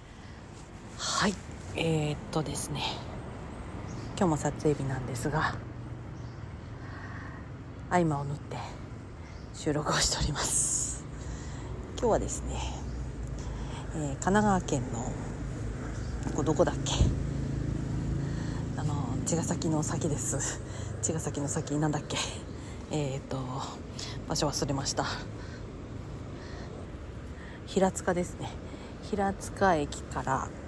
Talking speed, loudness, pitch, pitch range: 175 characters per minute, -32 LUFS, 130 Hz, 110-145 Hz